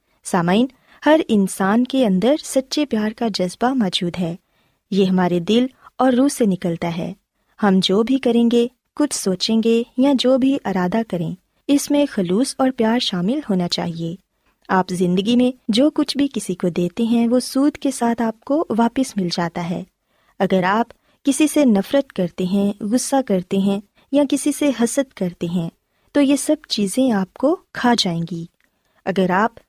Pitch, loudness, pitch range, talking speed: 230 Hz, -19 LUFS, 190-265 Hz, 175 wpm